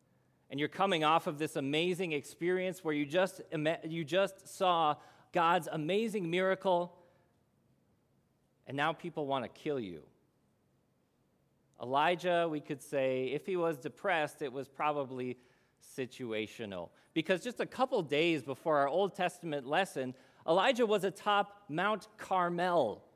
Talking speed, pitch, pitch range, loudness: 130 wpm, 165 Hz, 145-185 Hz, -34 LUFS